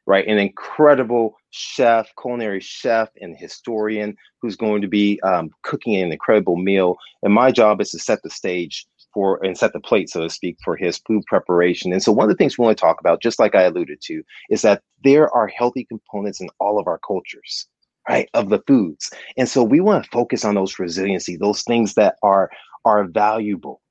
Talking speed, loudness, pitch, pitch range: 210 wpm, -18 LUFS, 105 Hz, 95-120 Hz